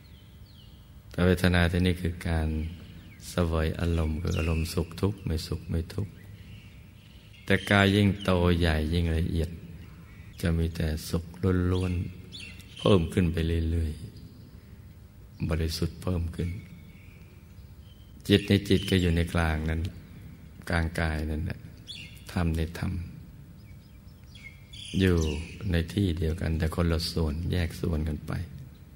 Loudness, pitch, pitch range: -28 LUFS, 85 Hz, 80-95 Hz